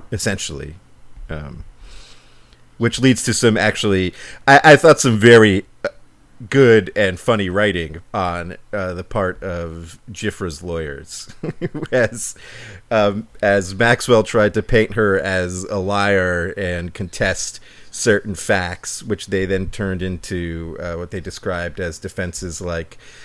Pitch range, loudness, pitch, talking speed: 90-110 Hz, -17 LUFS, 100 Hz, 130 wpm